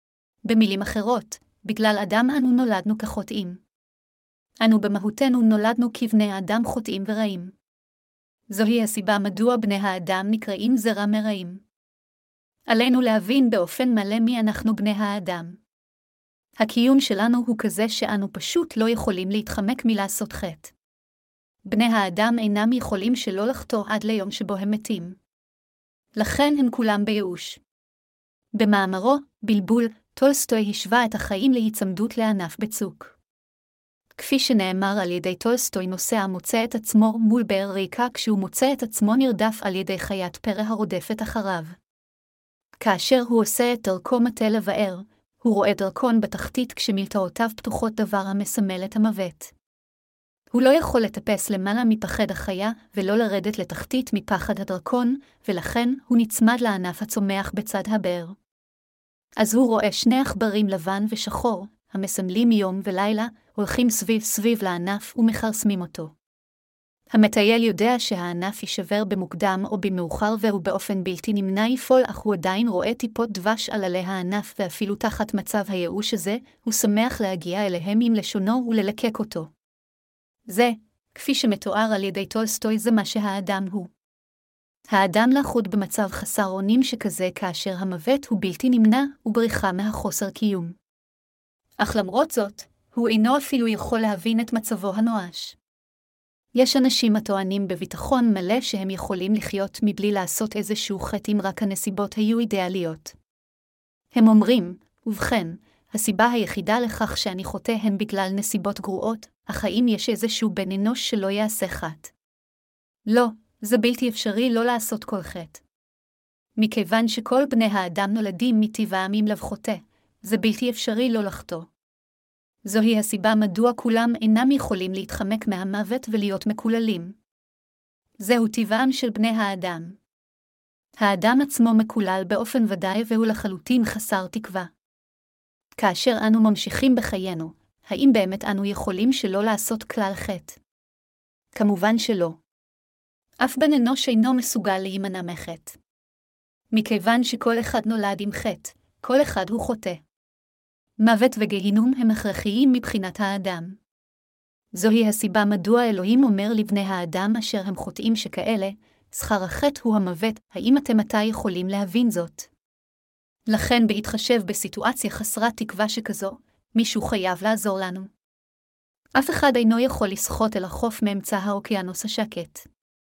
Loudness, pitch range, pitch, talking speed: -23 LUFS, 195-230 Hz, 215 Hz, 130 wpm